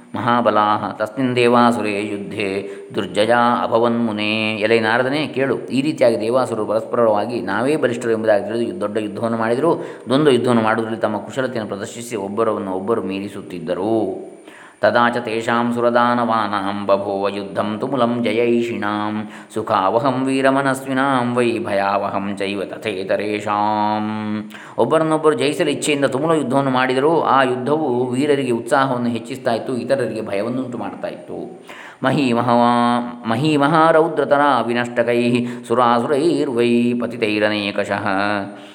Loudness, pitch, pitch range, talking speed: -18 LUFS, 115 Hz, 105-120 Hz, 95 wpm